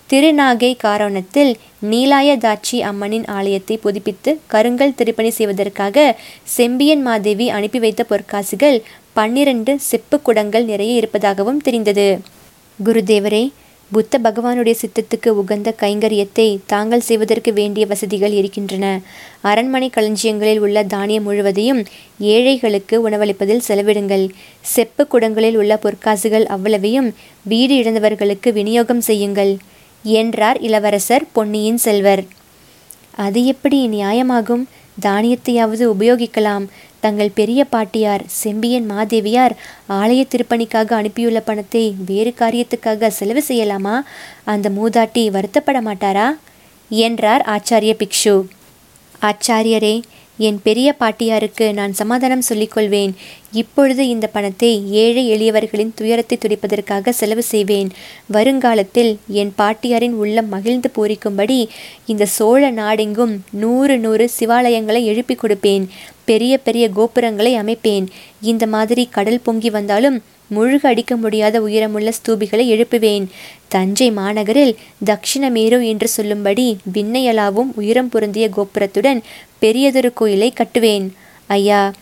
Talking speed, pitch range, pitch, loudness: 100 wpm, 210-235 Hz, 220 Hz, -15 LUFS